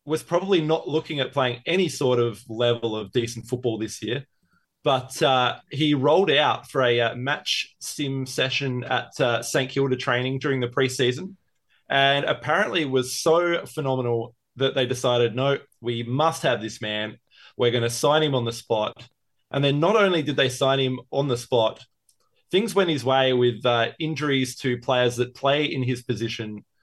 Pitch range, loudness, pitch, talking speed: 120-145 Hz, -23 LUFS, 130 Hz, 180 wpm